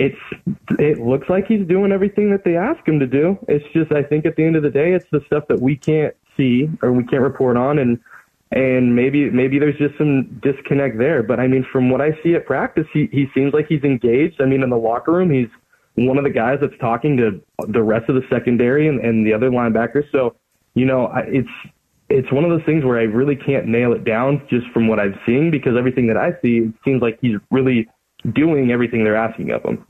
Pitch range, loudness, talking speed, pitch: 120-150 Hz, -17 LUFS, 245 wpm, 135 Hz